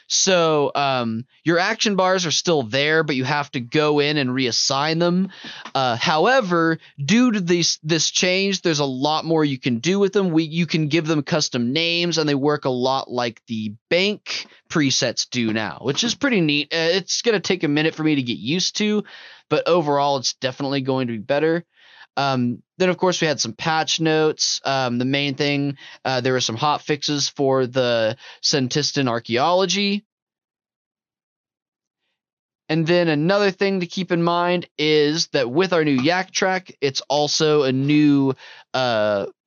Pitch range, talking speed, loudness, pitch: 135-175 Hz, 180 wpm, -20 LUFS, 150 Hz